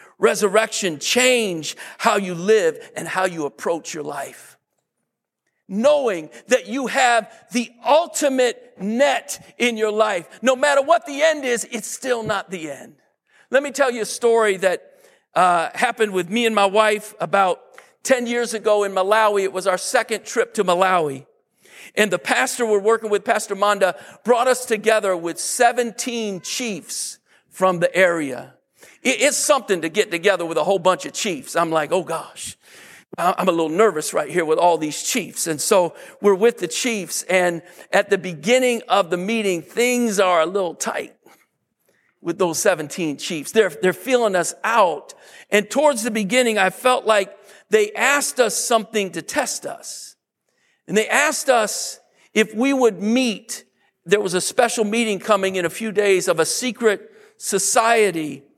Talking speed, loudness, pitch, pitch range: 170 wpm, -19 LUFS, 215 Hz, 185-245 Hz